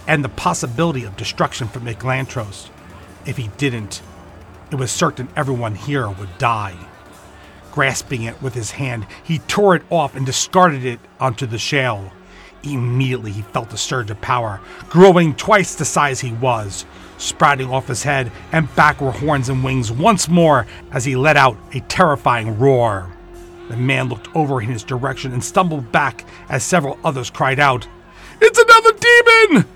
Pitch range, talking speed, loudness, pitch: 110-150 Hz, 165 wpm, -16 LUFS, 130 Hz